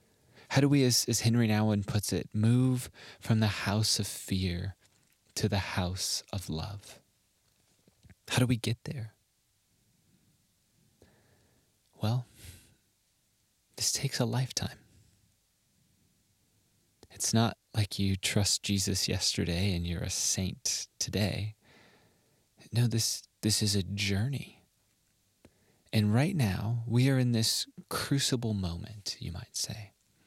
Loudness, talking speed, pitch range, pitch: -30 LUFS, 120 wpm, 100-120 Hz, 105 Hz